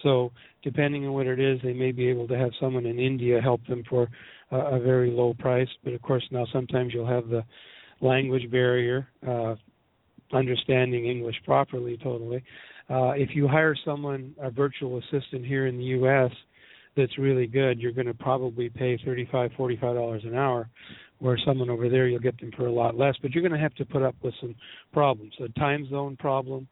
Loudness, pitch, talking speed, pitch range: -27 LUFS, 130 Hz, 200 wpm, 120-135 Hz